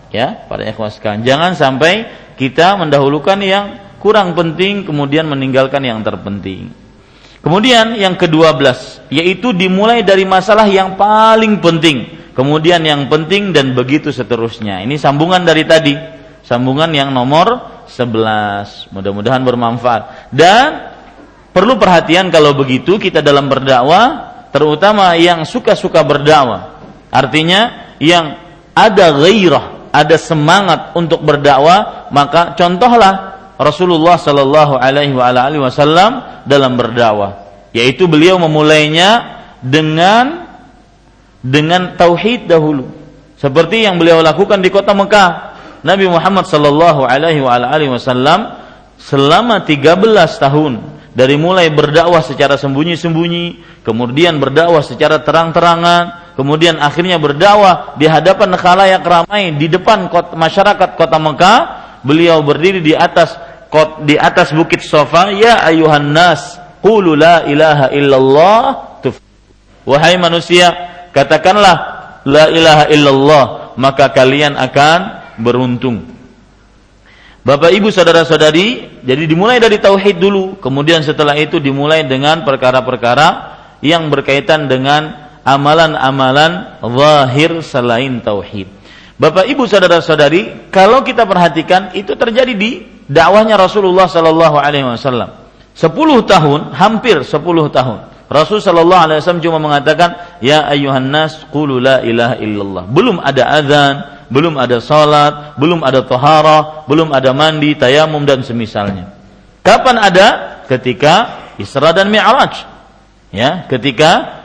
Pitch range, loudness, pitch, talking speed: 140-175 Hz, -9 LUFS, 155 Hz, 110 wpm